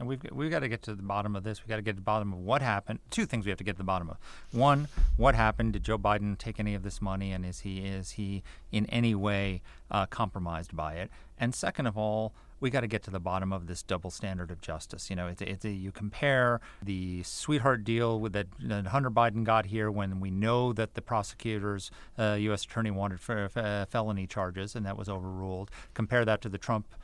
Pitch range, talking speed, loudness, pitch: 95-115 Hz, 250 wpm, -32 LUFS, 105 Hz